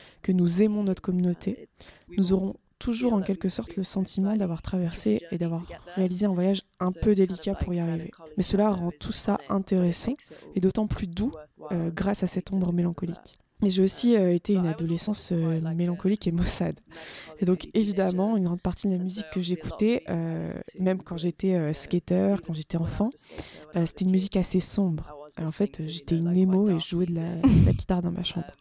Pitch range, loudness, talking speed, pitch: 175-195 Hz, -27 LUFS, 200 wpm, 185 Hz